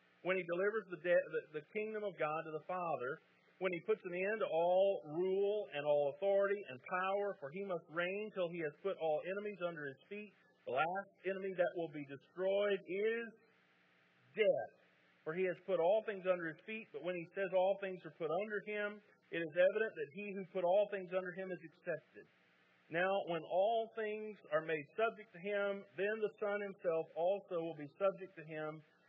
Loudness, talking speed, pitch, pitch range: -39 LUFS, 200 wpm, 185 Hz, 160-205 Hz